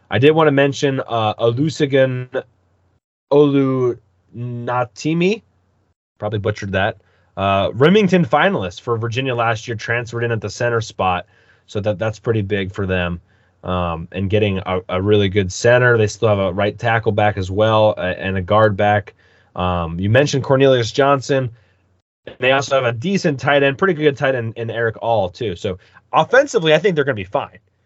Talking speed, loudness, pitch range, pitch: 180 wpm, -17 LUFS, 95-135 Hz, 110 Hz